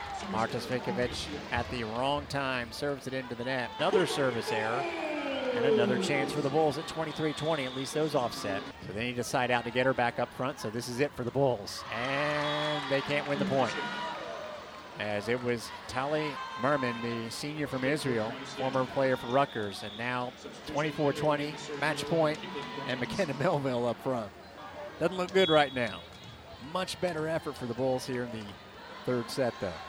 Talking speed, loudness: 185 wpm, -31 LUFS